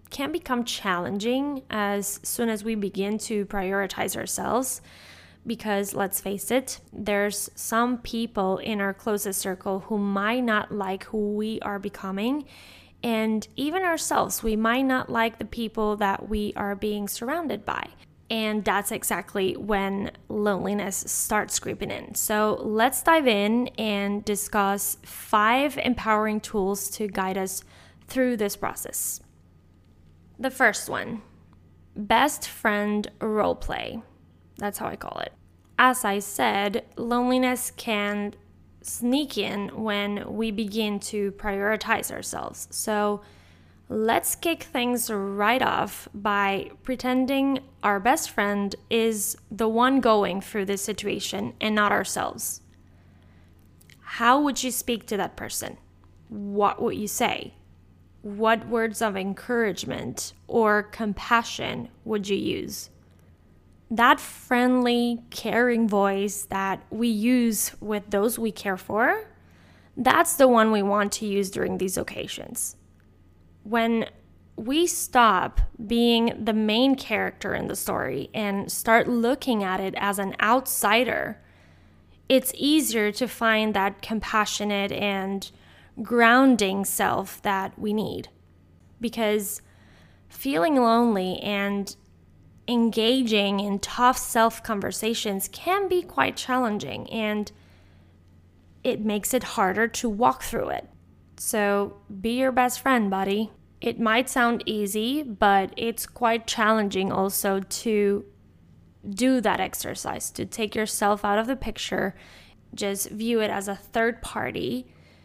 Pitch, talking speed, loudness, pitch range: 210 Hz, 125 wpm, -25 LUFS, 200-235 Hz